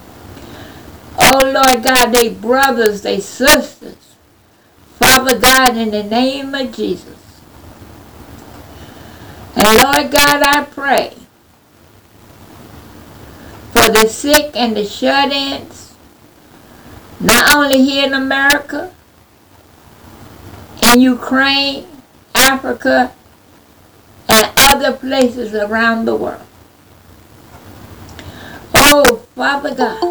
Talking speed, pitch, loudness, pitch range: 85 wpm, 255 Hz, -11 LUFS, 210-275 Hz